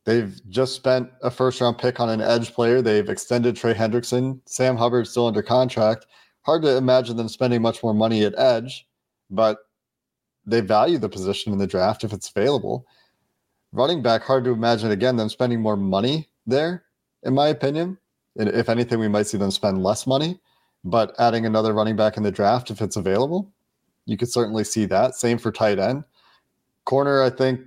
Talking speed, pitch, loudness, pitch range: 190 wpm, 120 Hz, -21 LUFS, 110-130 Hz